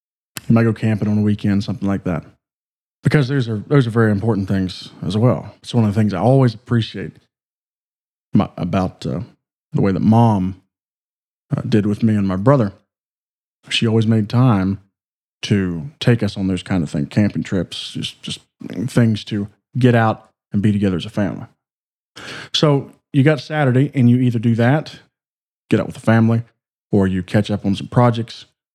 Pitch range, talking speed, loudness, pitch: 100-120 Hz, 185 wpm, -18 LUFS, 110 Hz